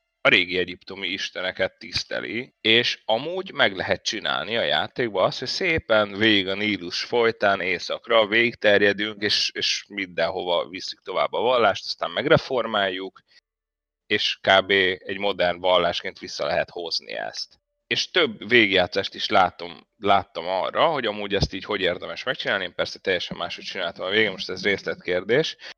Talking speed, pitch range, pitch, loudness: 145 wpm, 90-110 Hz, 100 Hz, -23 LUFS